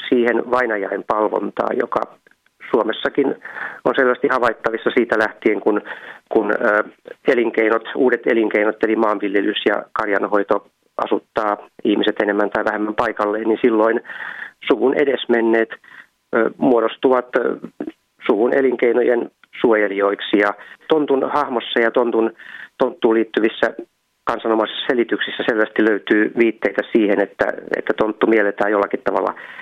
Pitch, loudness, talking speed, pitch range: 110 Hz, -18 LUFS, 105 wpm, 105-120 Hz